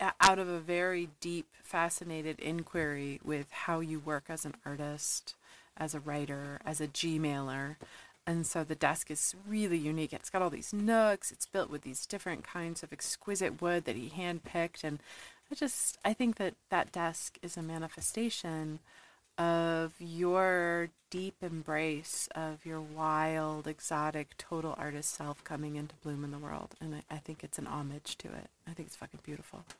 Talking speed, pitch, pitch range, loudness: 175 wpm, 160 Hz, 150-175 Hz, -35 LUFS